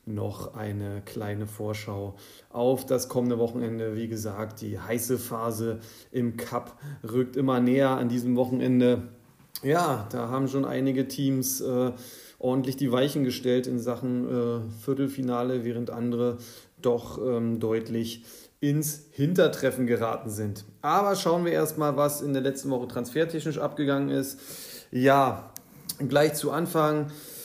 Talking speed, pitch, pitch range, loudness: 135 wpm, 125 Hz, 115-135 Hz, -27 LUFS